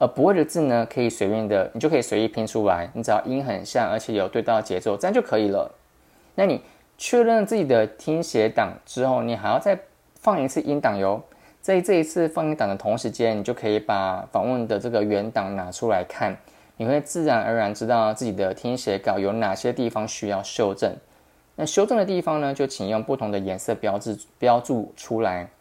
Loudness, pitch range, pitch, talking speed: -23 LUFS, 105-145 Hz, 115 Hz, 315 characters per minute